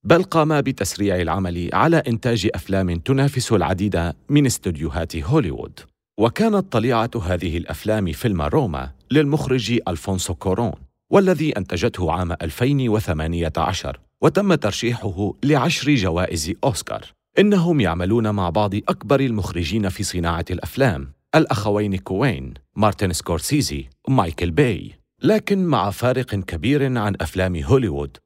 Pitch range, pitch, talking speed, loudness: 90-130 Hz, 105 Hz, 110 wpm, -20 LUFS